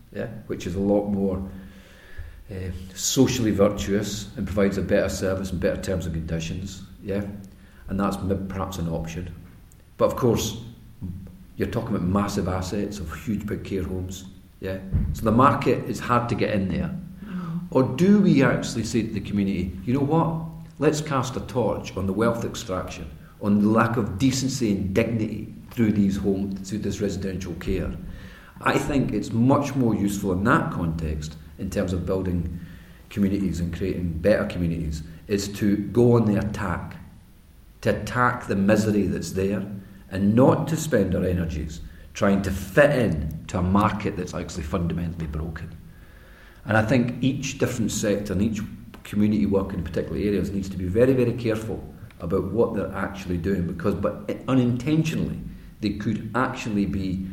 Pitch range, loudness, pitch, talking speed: 90-110 Hz, -24 LUFS, 100 Hz, 165 wpm